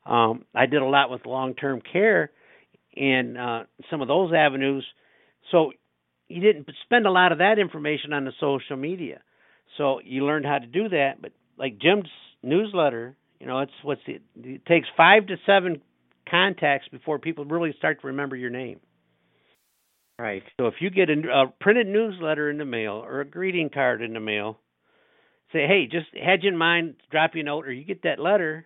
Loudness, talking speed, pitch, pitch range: -23 LUFS, 195 wpm, 145 Hz, 130-170 Hz